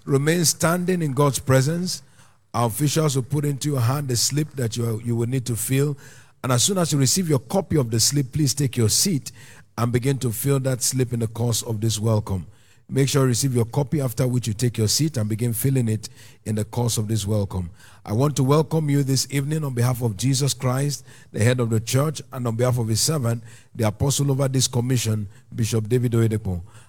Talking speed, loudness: 225 wpm, -22 LUFS